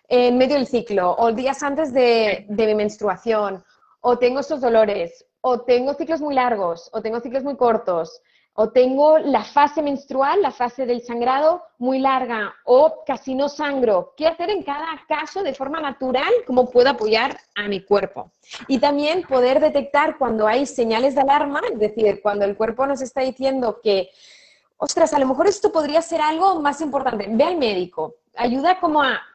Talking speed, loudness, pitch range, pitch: 180 wpm, -20 LUFS, 225-295 Hz, 260 Hz